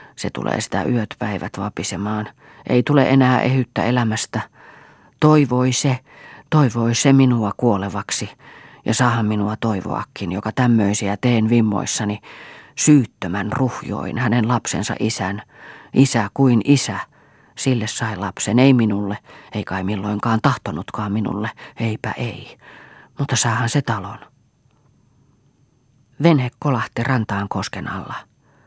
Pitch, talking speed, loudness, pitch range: 115 Hz, 115 wpm, -19 LUFS, 105-130 Hz